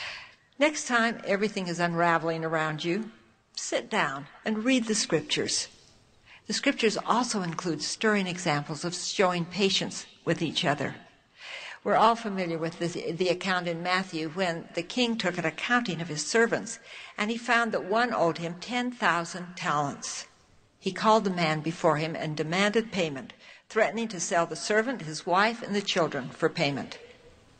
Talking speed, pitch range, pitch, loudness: 160 wpm, 165-220 Hz, 185 Hz, -28 LUFS